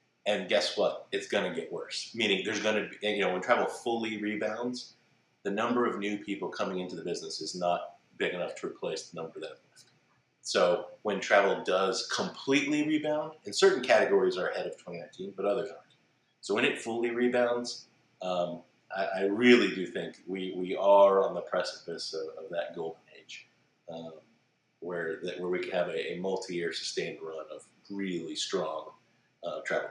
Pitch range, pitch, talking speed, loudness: 95-140 Hz, 110 Hz, 185 wpm, -30 LUFS